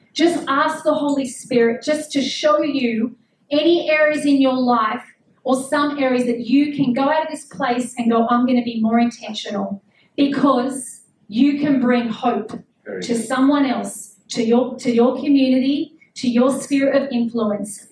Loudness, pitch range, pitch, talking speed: -19 LUFS, 235-280 Hz, 255 Hz, 165 wpm